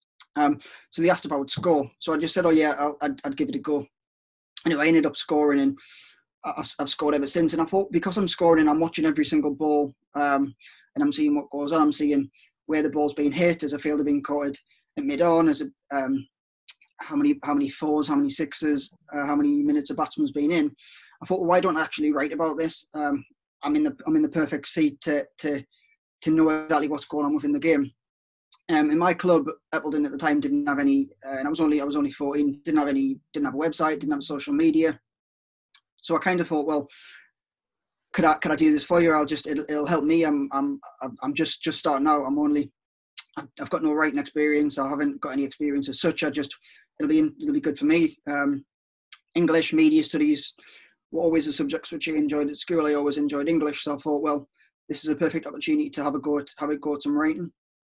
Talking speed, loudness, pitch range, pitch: 240 wpm, -24 LUFS, 145-170 Hz, 150 Hz